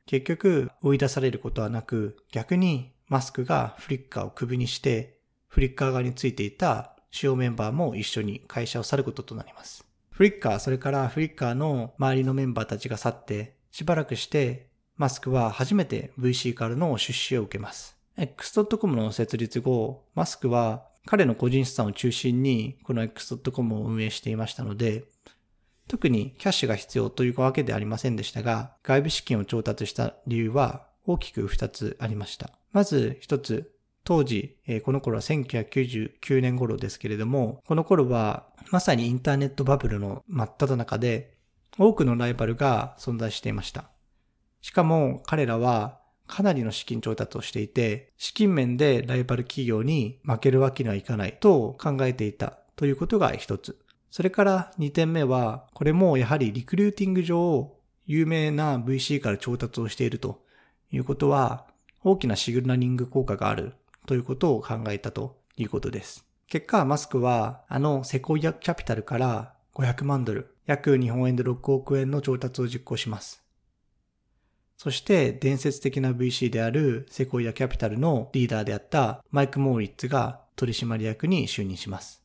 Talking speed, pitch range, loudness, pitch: 345 characters per minute, 115-140 Hz, -26 LUFS, 130 Hz